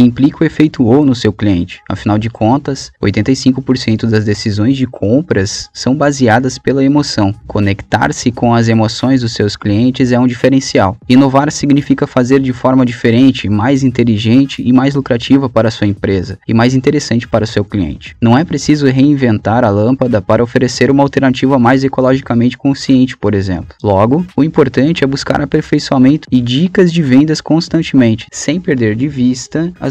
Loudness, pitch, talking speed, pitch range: -11 LUFS, 130 Hz, 165 wpm, 110-140 Hz